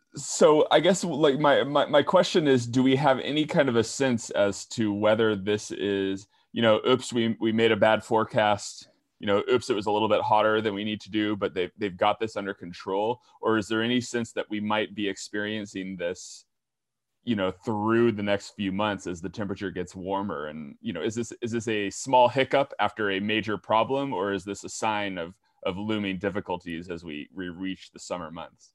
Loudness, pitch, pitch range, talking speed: -26 LUFS, 105 Hz, 100-115 Hz, 220 wpm